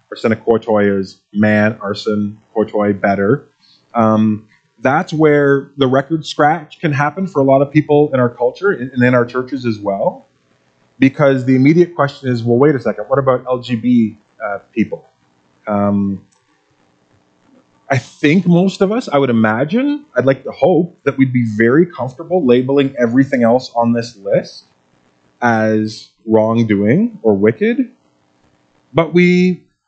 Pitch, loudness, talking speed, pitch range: 125 Hz, -14 LUFS, 150 wpm, 105-145 Hz